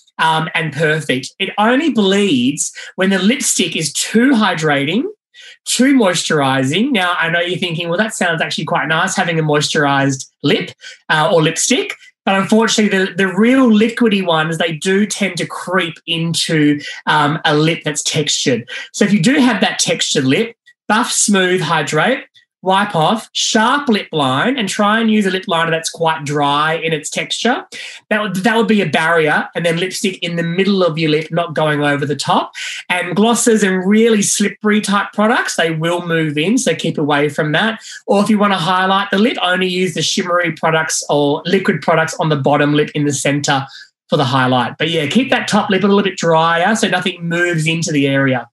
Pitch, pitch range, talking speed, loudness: 180 Hz, 160-215 Hz, 195 wpm, -14 LUFS